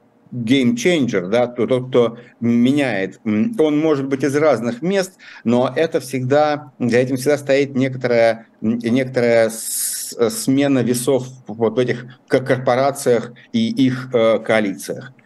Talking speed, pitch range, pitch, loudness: 115 wpm, 120-140 Hz, 125 Hz, -18 LUFS